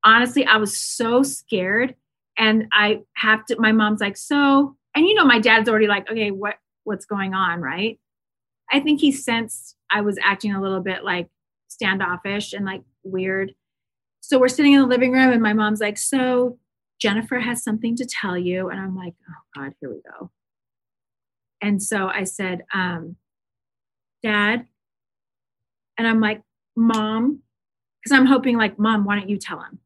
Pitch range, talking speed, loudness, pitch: 190-235 Hz, 175 wpm, -19 LUFS, 210 Hz